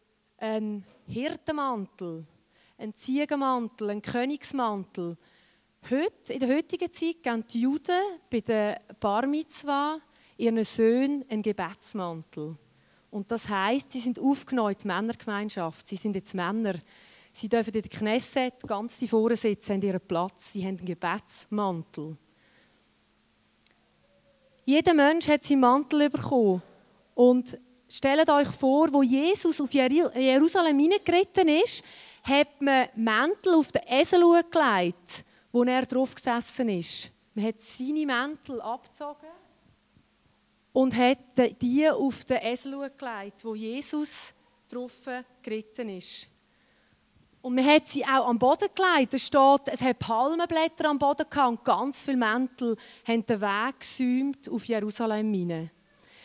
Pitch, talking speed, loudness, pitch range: 250 Hz, 125 wpm, -26 LUFS, 215-285 Hz